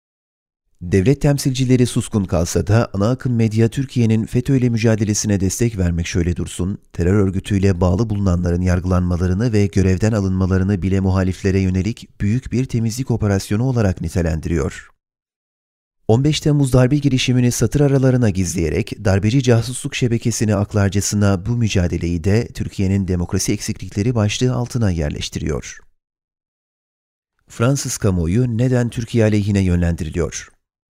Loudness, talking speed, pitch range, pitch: -18 LUFS, 115 wpm, 95-120 Hz, 105 Hz